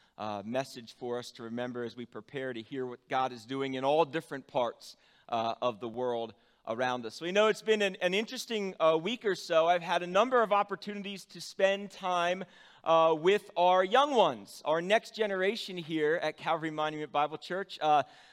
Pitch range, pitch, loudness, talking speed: 130-195 Hz, 160 Hz, -31 LUFS, 200 wpm